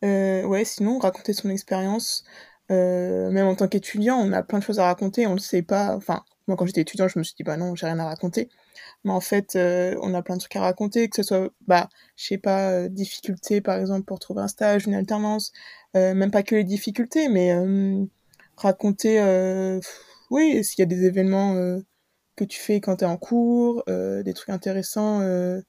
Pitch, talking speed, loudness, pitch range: 195 Hz, 225 wpm, -23 LUFS, 185-210 Hz